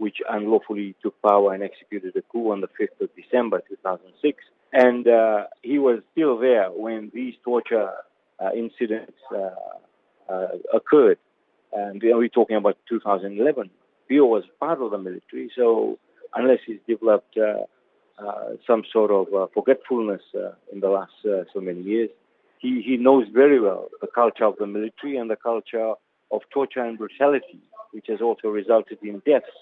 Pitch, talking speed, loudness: 115 Hz, 165 wpm, -22 LUFS